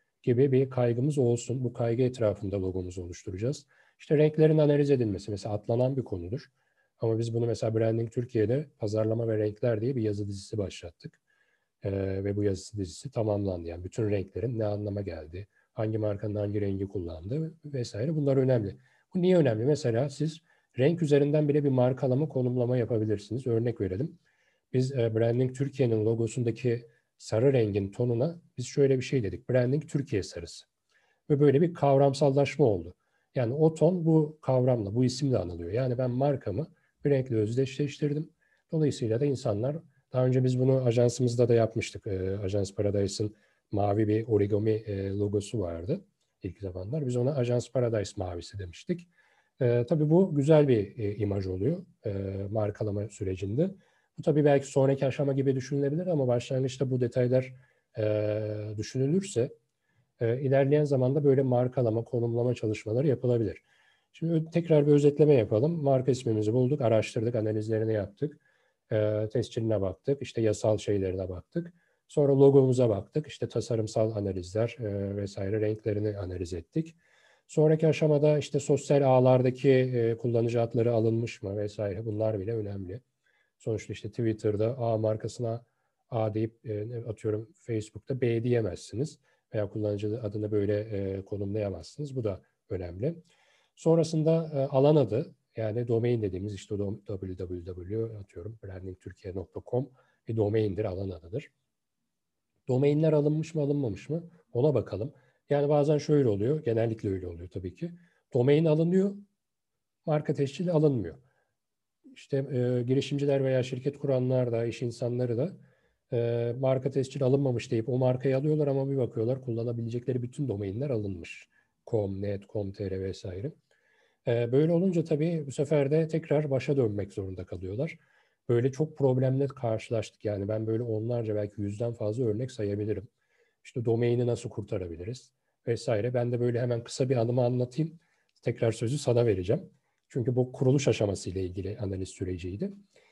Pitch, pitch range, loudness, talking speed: 120 Hz, 105-140 Hz, -29 LUFS, 140 wpm